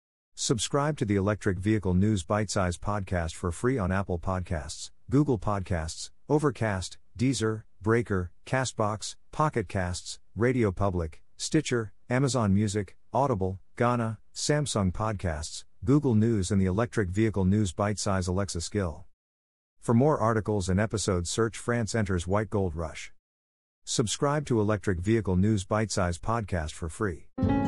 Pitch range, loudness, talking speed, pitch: 90-115 Hz, -28 LUFS, 135 wpm, 105 Hz